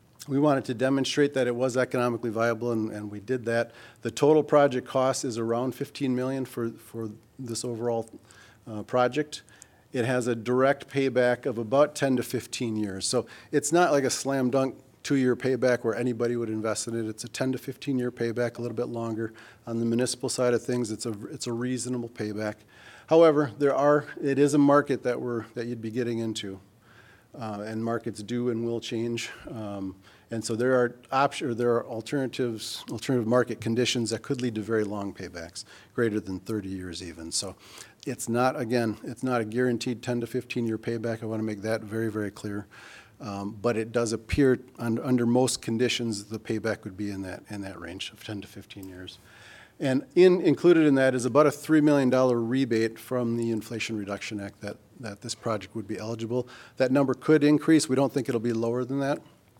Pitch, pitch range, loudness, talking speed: 120 Hz, 110-130 Hz, -27 LUFS, 200 wpm